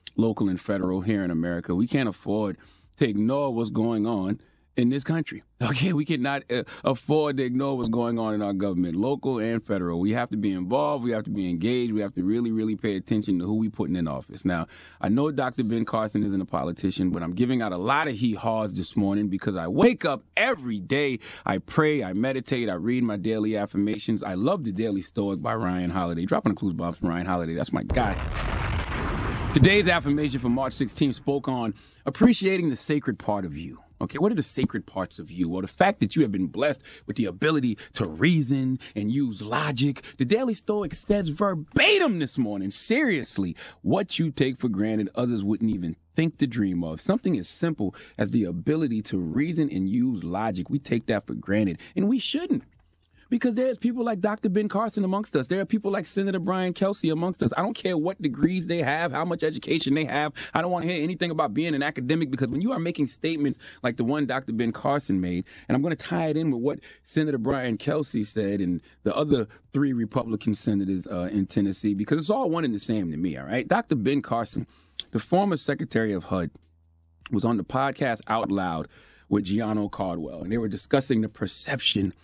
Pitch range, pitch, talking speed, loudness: 100-150 Hz, 120 Hz, 215 wpm, -26 LUFS